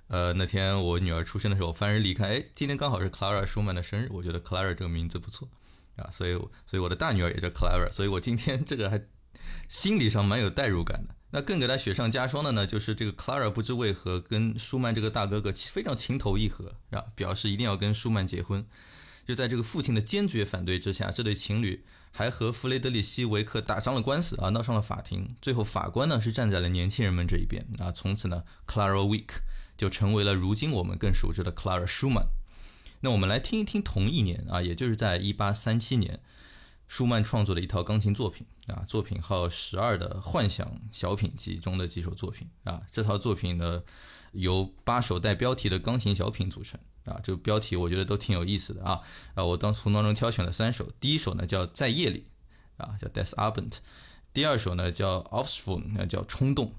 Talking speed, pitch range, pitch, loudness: 365 characters per minute, 95-115 Hz, 105 Hz, -29 LUFS